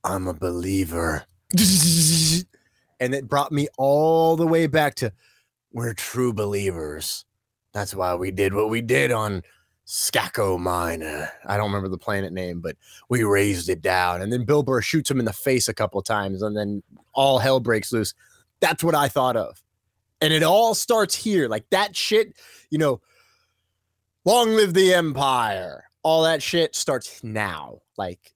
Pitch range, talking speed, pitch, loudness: 95-155 Hz, 170 wpm, 115 Hz, -22 LUFS